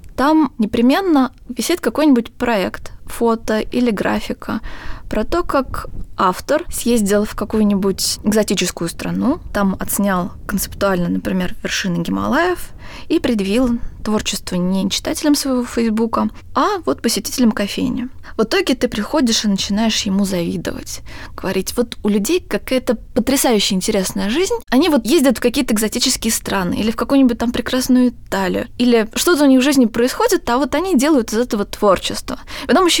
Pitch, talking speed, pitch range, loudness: 235 Hz, 145 wpm, 205-270 Hz, -17 LUFS